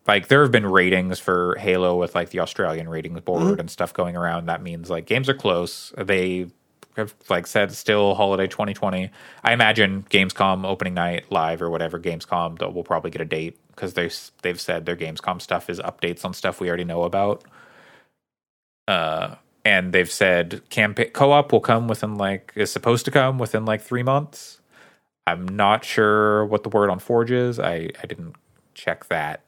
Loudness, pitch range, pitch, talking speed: -21 LUFS, 85-110 Hz, 95 Hz, 185 wpm